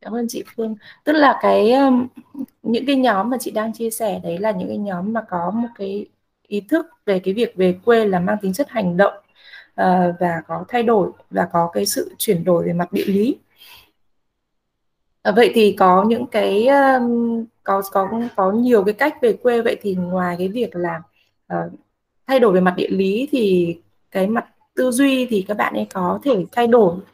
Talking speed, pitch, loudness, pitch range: 200 wpm, 210 Hz, -18 LUFS, 185-240 Hz